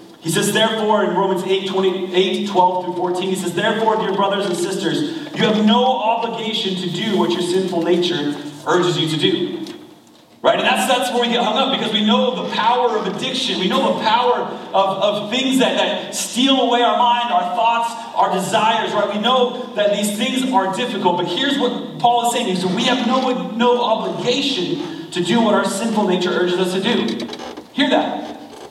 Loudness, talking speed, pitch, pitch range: -18 LUFS, 205 wpm, 215 Hz, 185-245 Hz